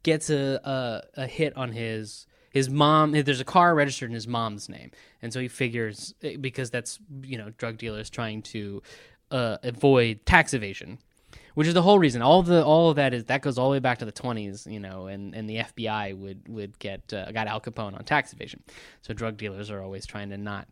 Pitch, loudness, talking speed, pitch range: 120 Hz, -25 LUFS, 230 wpm, 105-135 Hz